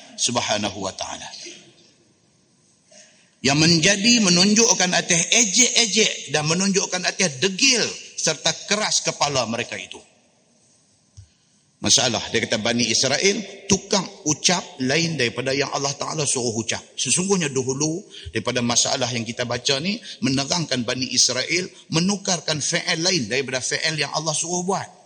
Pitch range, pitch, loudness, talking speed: 130-190 Hz, 160 Hz, -20 LUFS, 120 wpm